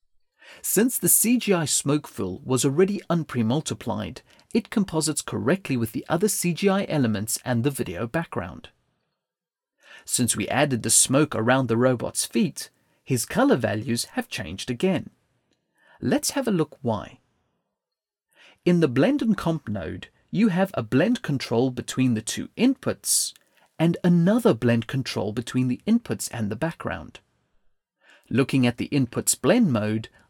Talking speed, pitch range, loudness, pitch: 140 wpm, 115-175 Hz, -23 LUFS, 135 Hz